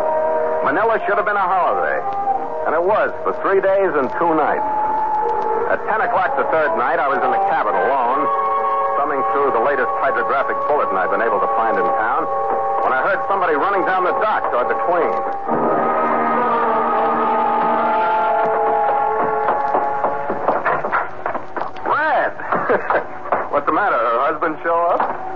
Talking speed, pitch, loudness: 135 wpm, 185 Hz, -18 LUFS